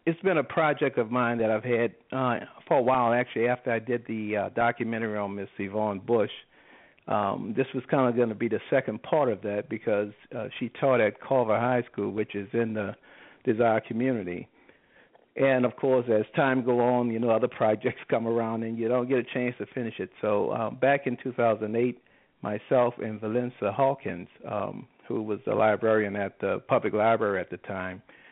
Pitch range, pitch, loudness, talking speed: 110-125 Hz, 115 Hz, -27 LUFS, 200 wpm